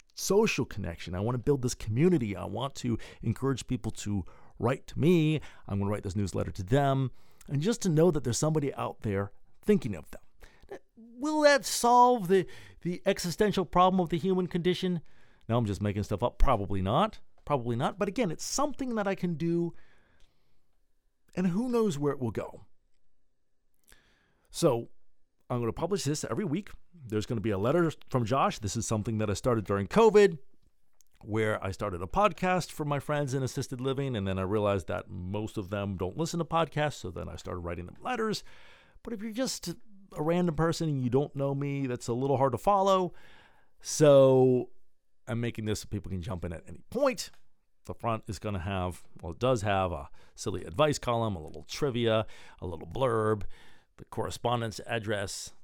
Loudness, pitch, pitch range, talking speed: -30 LUFS, 130 Hz, 105-170 Hz, 195 wpm